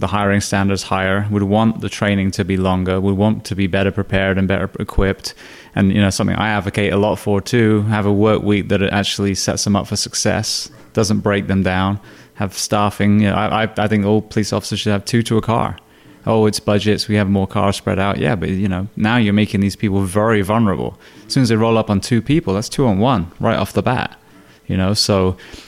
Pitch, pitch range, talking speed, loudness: 105 Hz, 100-110 Hz, 235 wpm, -17 LUFS